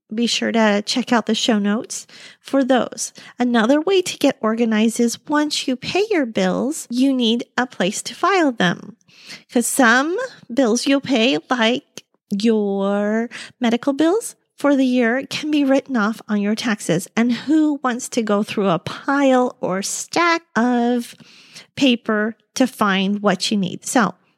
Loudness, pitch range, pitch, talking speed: -19 LUFS, 215-270 Hz, 240 Hz, 160 wpm